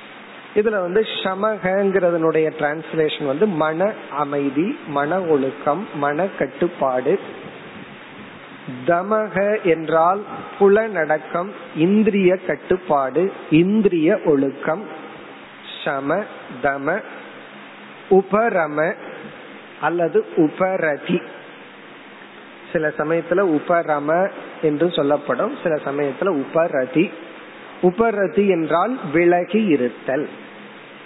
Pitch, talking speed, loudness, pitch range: 165 Hz, 70 wpm, -20 LUFS, 145-195 Hz